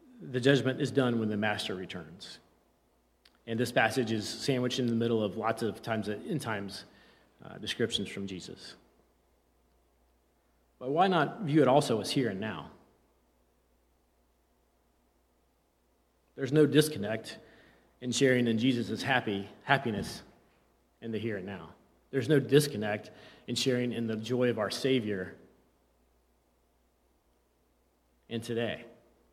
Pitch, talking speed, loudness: 105 Hz, 125 wpm, -30 LUFS